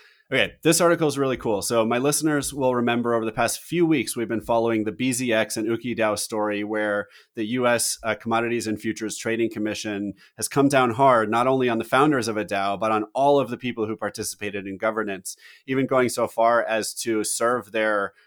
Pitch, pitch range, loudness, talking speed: 115 Hz, 110-125 Hz, -23 LUFS, 210 wpm